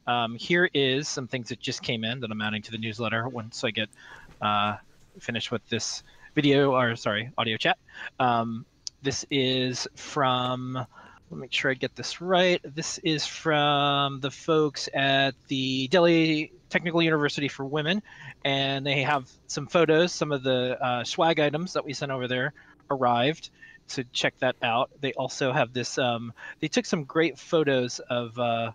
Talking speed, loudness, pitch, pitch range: 175 wpm, -26 LUFS, 135 Hz, 120-150 Hz